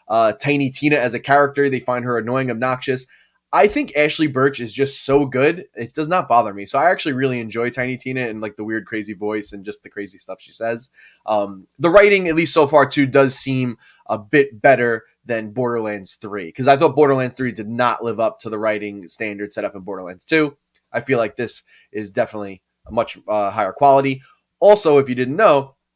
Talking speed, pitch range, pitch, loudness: 215 wpm, 110-140 Hz, 125 Hz, -18 LUFS